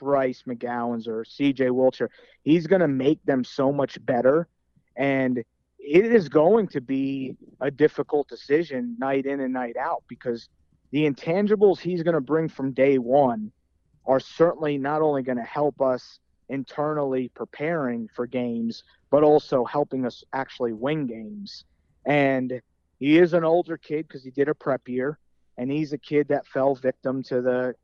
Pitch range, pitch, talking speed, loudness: 125-150 Hz, 135 Hz, 165 wpm, -24 LUFS